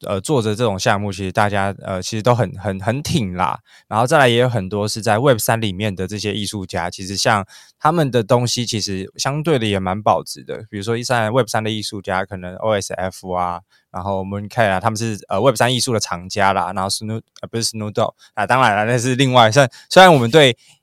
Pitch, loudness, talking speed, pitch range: 110 Hz, -17 LUFS, 375 characters per minute, 100-120 Hz